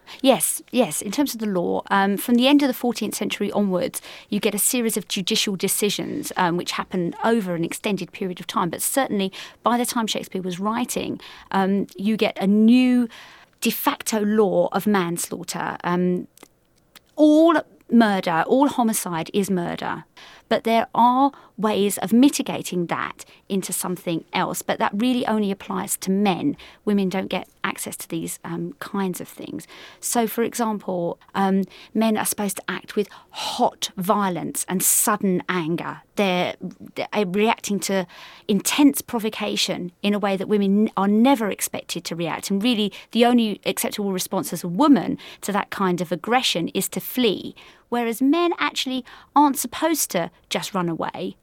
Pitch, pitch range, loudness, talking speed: 205 Hz, 185-235 Hz, -22 LUFS, 165 wpm